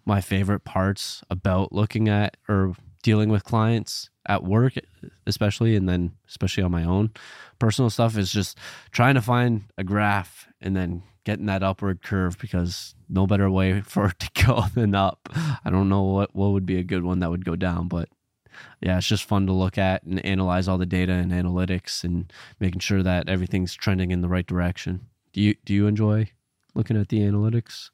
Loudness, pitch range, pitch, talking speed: -24 LUFS, 90-105 Hz, 95 Hz, 200 wpm